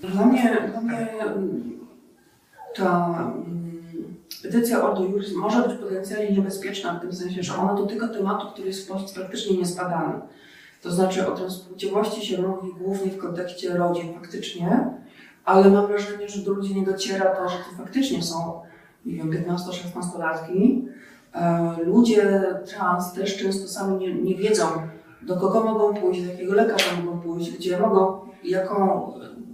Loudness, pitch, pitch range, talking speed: -24 LUFS, 190 Hz, 180-205 Hz, 150 wpm